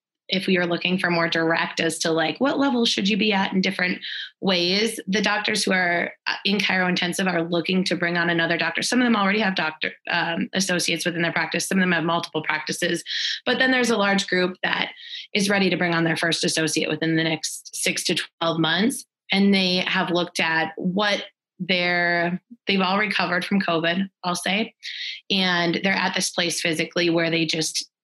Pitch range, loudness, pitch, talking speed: 170-195 Hz, -22 LUFS, 180 Hz, 205 wpm